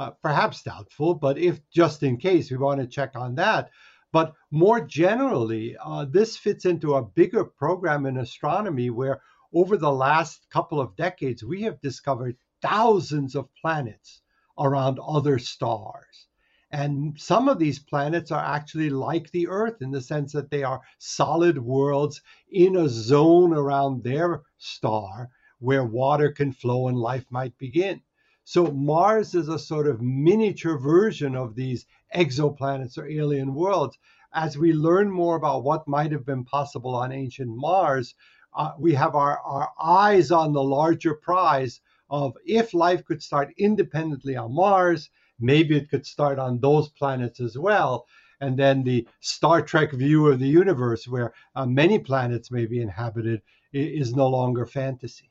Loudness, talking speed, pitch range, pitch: -23 LUFS, 160 wpm, 130-165 Hz, 145 Hz